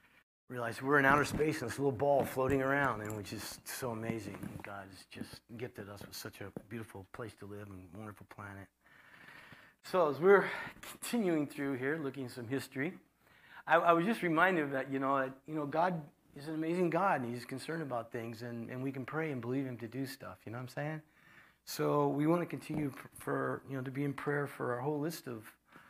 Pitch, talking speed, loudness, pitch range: 135 Hz, 220 wpm, -35 LUFS, 115-150 Hz